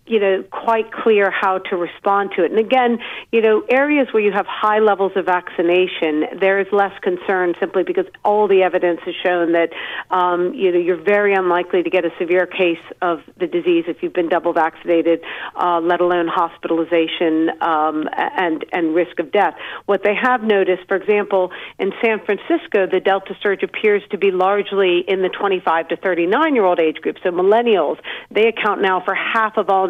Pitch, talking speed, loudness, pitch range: 185 Hz, 195 wpm, -17 LUFS, 175-205 Hz